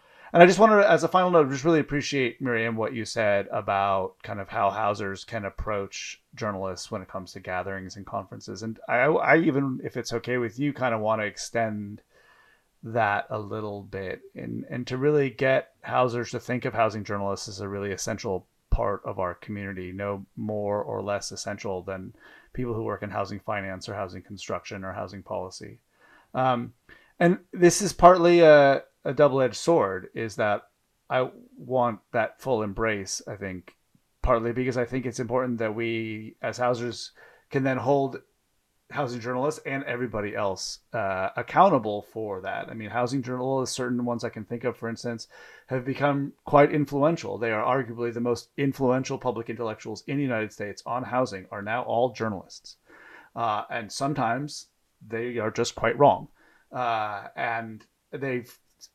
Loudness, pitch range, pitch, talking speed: -26 LUFS, 105-130 Hz, 115 Hz, 175 wpm